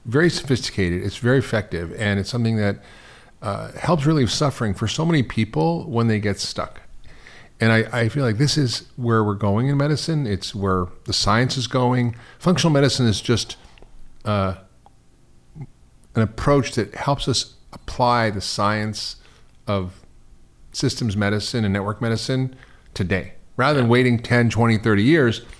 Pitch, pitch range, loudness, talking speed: 115 Hz, 100-130 Hz, -21 LUFS, 155 wpm